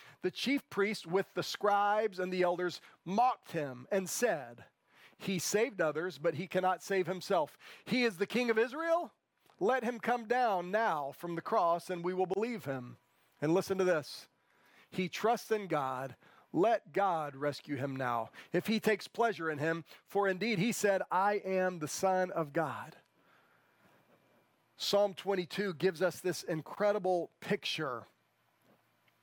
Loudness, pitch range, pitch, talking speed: -34 LUFS, 165-210 Hz, 185 Hz, 155 wpm